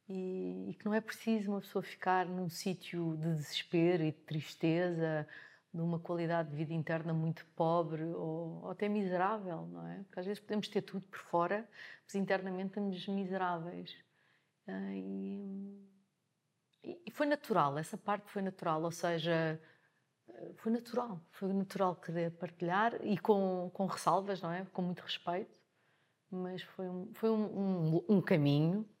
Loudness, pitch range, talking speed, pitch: -37 LUFS, 165-195 Hz, 145 wpm, 180 Hz